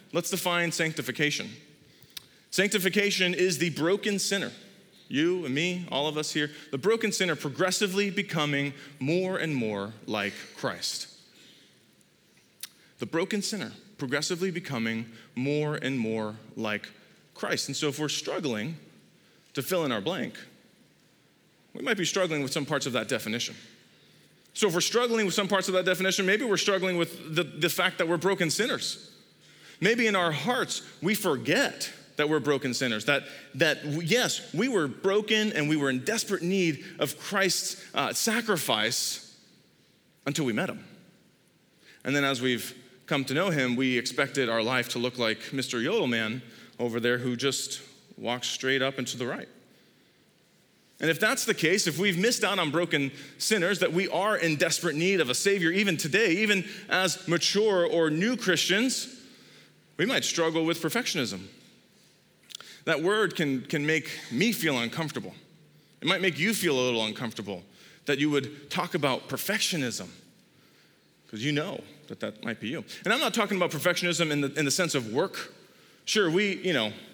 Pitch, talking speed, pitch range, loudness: 165 Hz, 165 wpm, 135-190 Hz, -27 LUFS